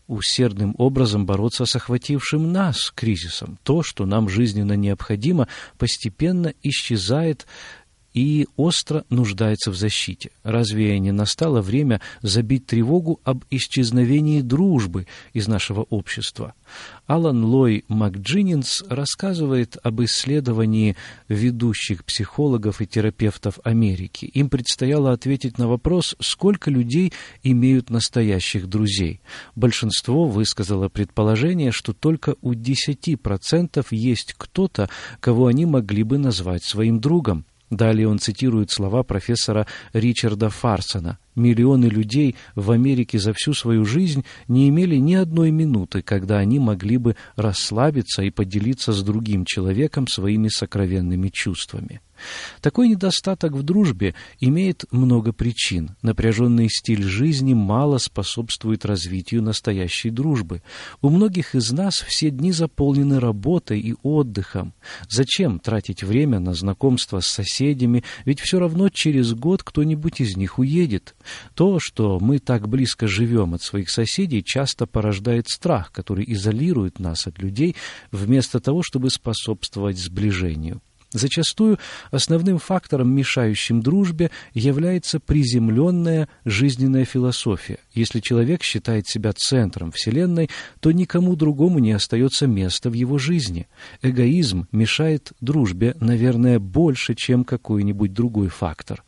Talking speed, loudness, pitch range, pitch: 120 wpm, -20 LUFS, 105-145 Hz, 120 Hz